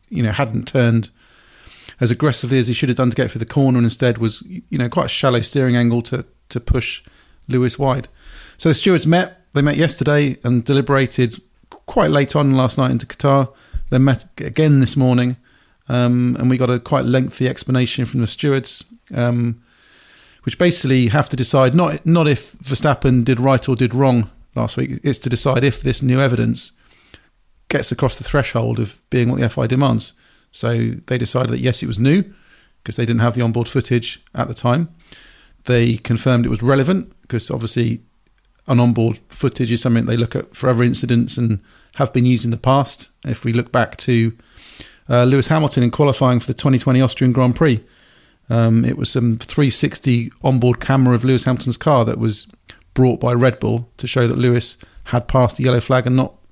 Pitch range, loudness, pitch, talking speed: 120-135 Hz, -17 LUFS, 125 Hz, 195 wpm